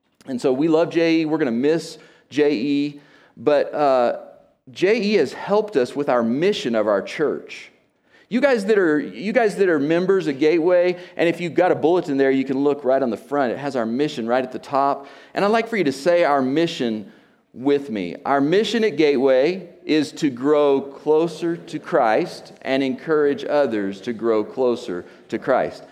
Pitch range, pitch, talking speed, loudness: 135-175 Hz, 150 Hz, 195 wpm, -20 LUFS